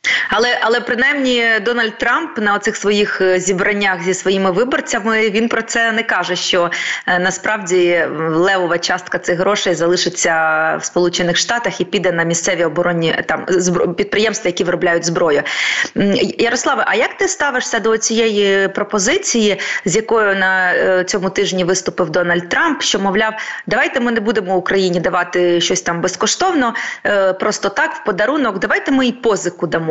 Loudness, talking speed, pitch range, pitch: -15 LUFS, 145 wpm, 180-225 Hz, 195 Hz